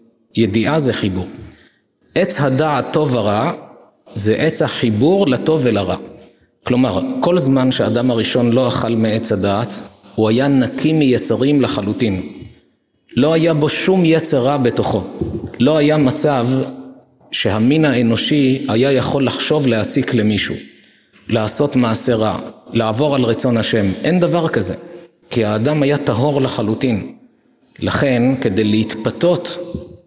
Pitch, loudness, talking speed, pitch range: 125 Hz, -16 LUFS, 120 wpm, 115-150 Hz